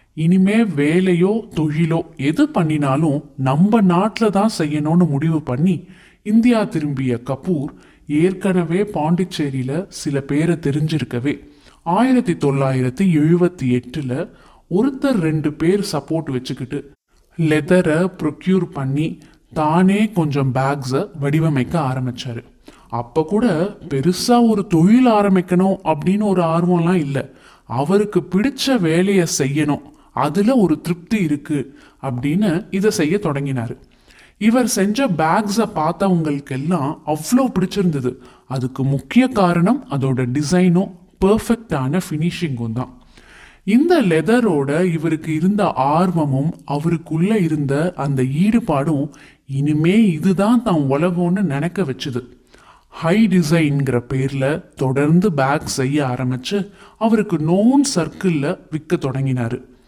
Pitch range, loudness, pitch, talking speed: 140-190 Hz, -18 LUFS, 165 Hz, 100 wpm